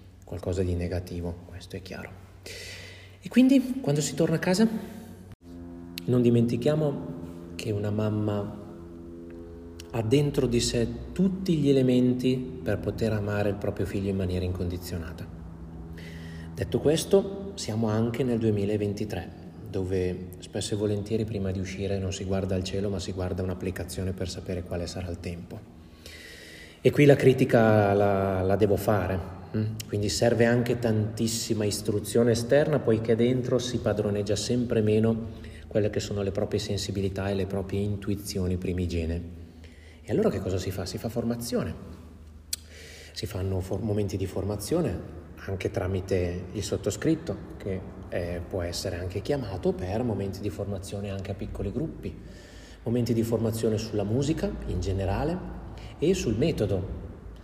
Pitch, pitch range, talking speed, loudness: 100 Hz, 90-115 Hz, 140 wpm, -28 LUFS